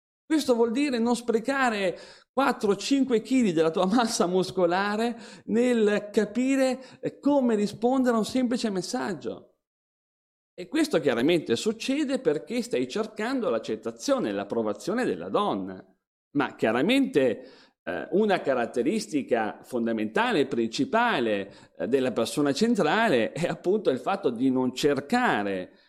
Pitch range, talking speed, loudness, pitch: 175-250 Hz, 110 wpm, -26 LUFS, 225 Hz